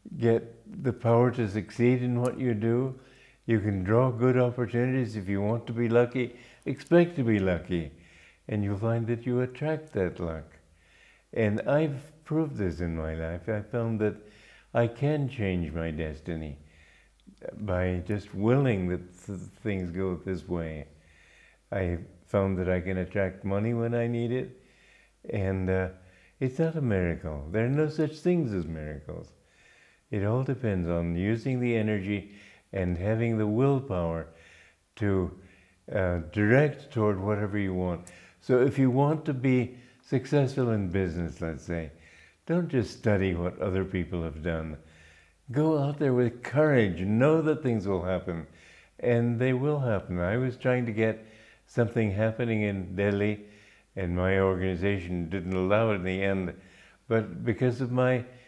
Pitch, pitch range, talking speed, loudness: 105 Hz, 90-125 Hz, 155 wpm, -28 LUFS